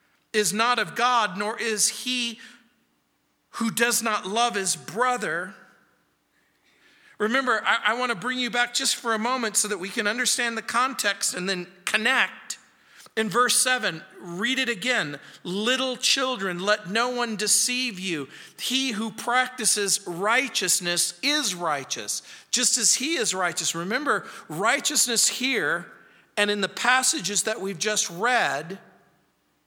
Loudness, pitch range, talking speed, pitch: -23 LUFS, 200-250 Hz, 140 wpm, 225 Hz